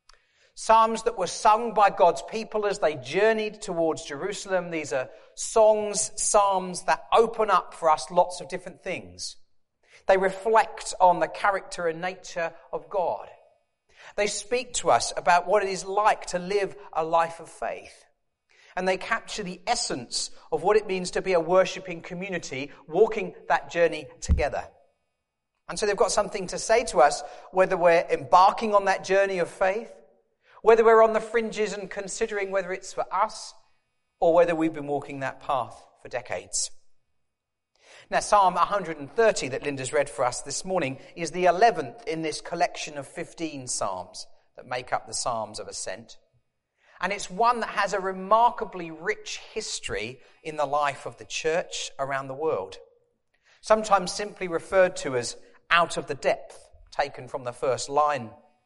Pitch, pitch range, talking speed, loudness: 185 Hz, 165-215 Hz, 165 wpm, -25 LUFS